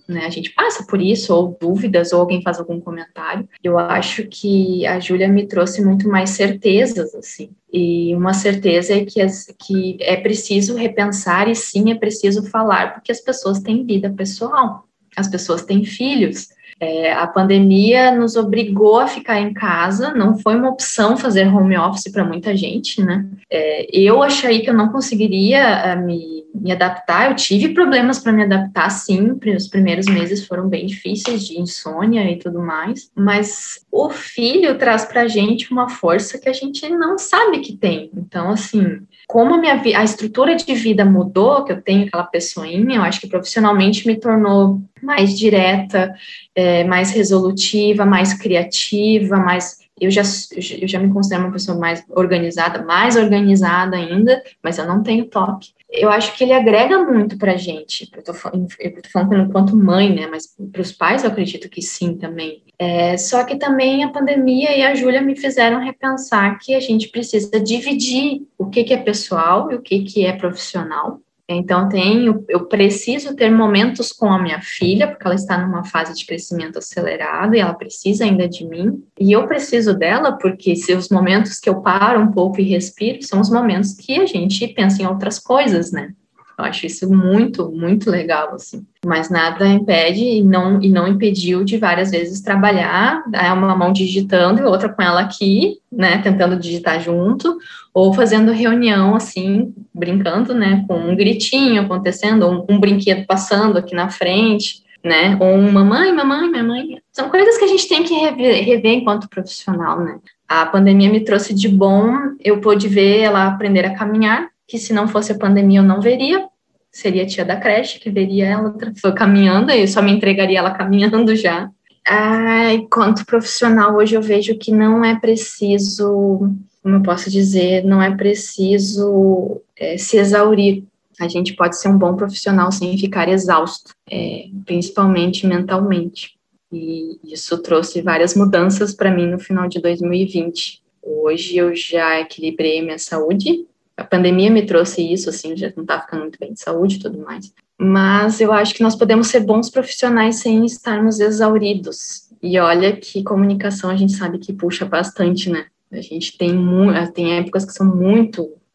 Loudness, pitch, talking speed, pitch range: -15 LUFS, 200 Hz, 175 wpm, 180-220 Hz